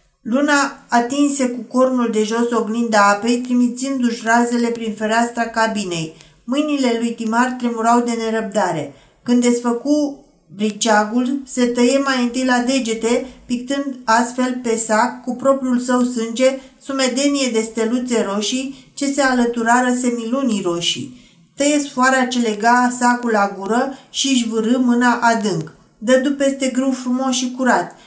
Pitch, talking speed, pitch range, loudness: 245 Hz, 135 wpm, 225-260 Hz, -17 LUFS